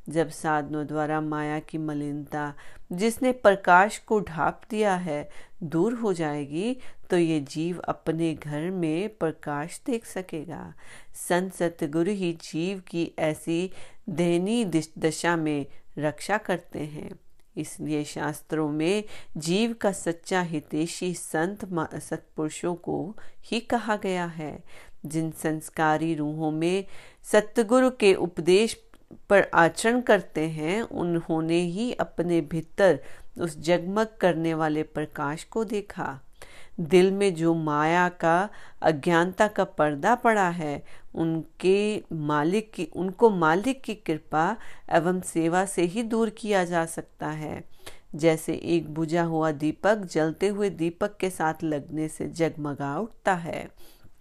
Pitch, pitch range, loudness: 170 Hz, 155-195 Hz, -26 LUFS